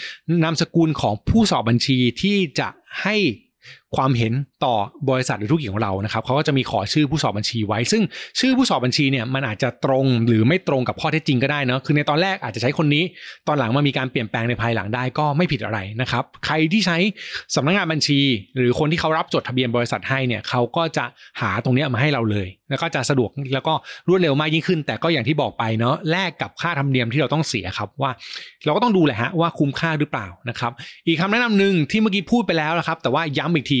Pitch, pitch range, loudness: 145 Hz, 125-165 Hz, -20 LUFS